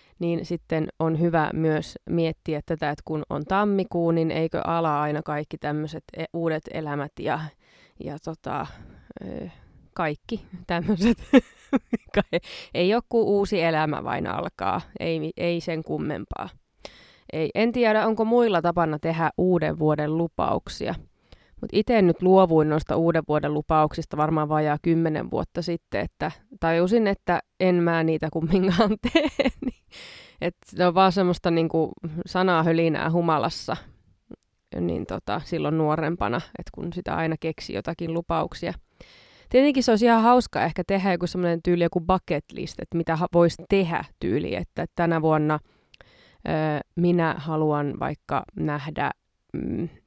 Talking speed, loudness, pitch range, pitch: 135 wpm, -24 LUFS, 155-185 Hz, 165 Hz